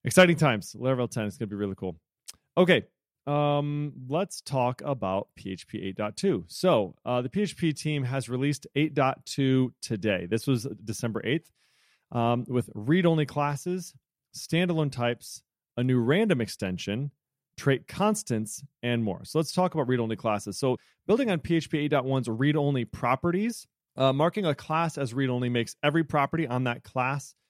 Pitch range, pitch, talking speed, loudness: 120-155 Hz, 135 Hz, 160 wpm, -28 LUFS